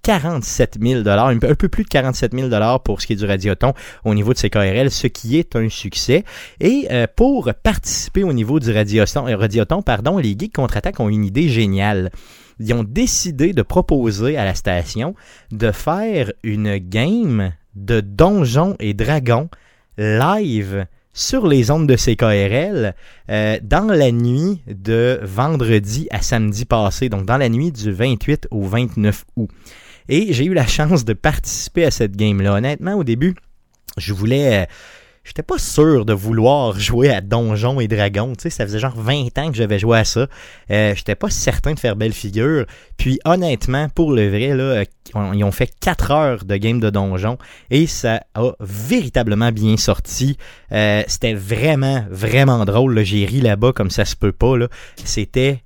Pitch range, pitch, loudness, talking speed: 105-140 Hz, 120 Hz, -17 LUFS, 175 wpm